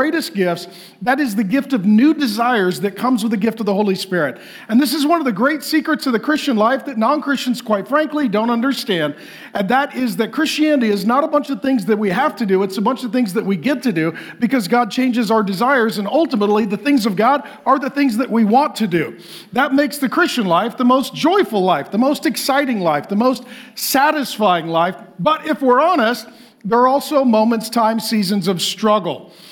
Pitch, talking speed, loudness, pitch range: 240 Hz, 225 wpm, -17 LUFS, 210-275 Hz